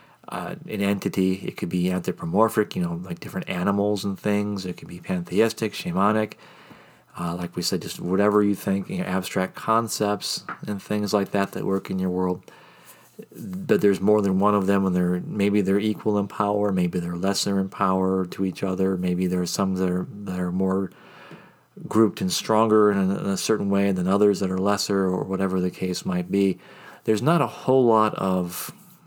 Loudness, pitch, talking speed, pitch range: -24 LUFS, 100 Hz, 200 wpm, 95-105 Hz